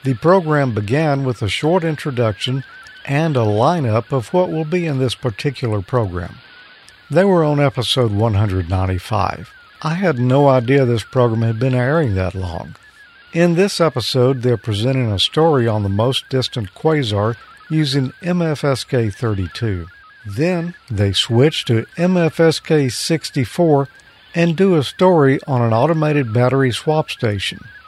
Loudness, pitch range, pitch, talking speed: -17 LUFS, 115-155 Hz, 135 Hz, 140 wpm